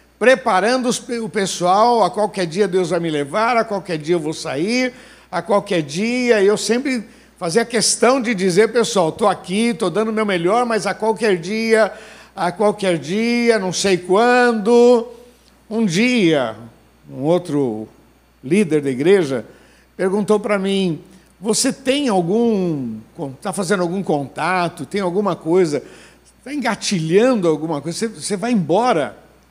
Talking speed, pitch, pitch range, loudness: 140 wpm, 205 Hz, 175-230 Hz, -18 LUFS